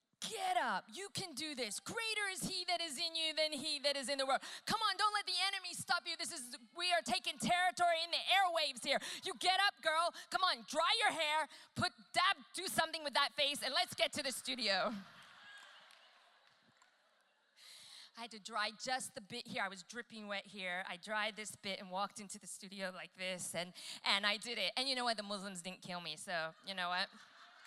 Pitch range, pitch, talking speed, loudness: 205-340 Hz, 275 Hz, 220 wpm, -37 LUFS